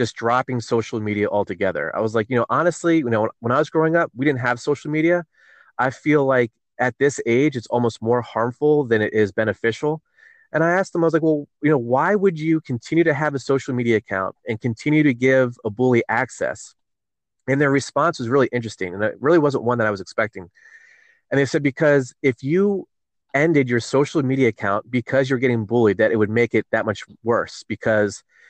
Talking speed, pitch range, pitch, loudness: 220 wpm, 115-155 Hz, 130 Hz, -20 LUFS